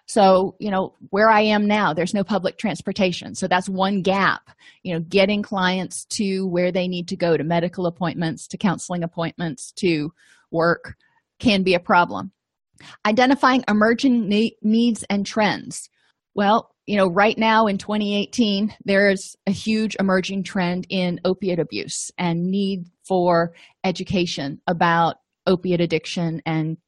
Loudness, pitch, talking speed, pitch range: -21 LUFS, 190 Hz, 150 wpm, 175-210 Hz